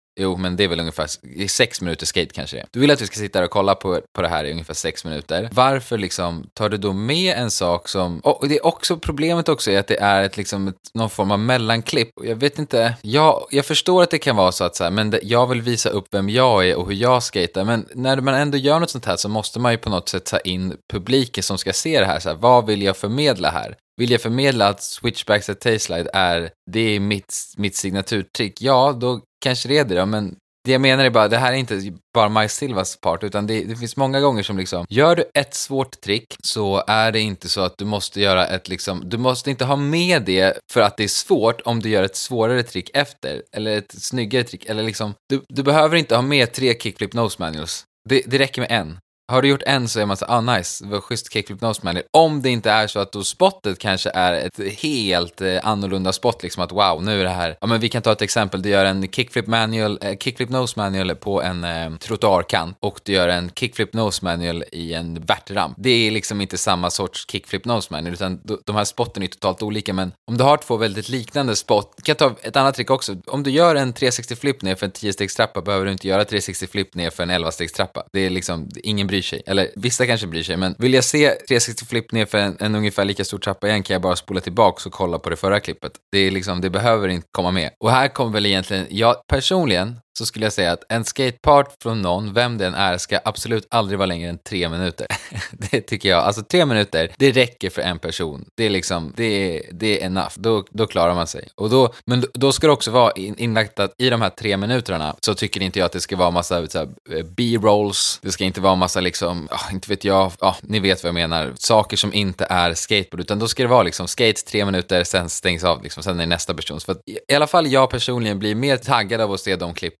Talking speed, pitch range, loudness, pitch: 250 wpm, 95-120 Hz, -19 LUFS, 105 Hz